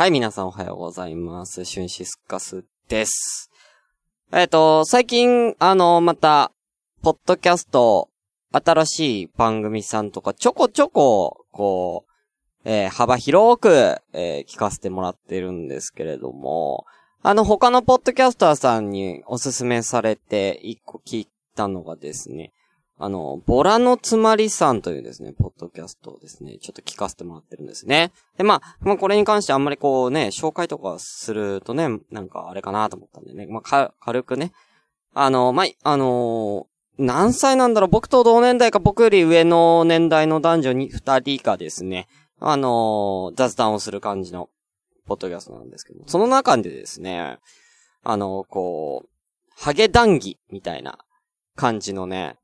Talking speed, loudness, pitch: 320 characters per minute, -19 LUFS, 135 Hz